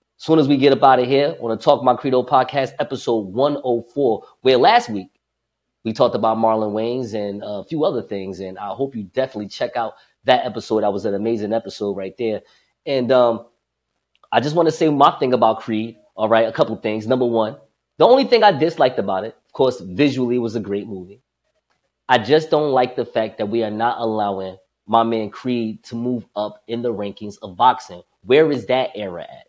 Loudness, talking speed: -19 LUFS, 220 wpm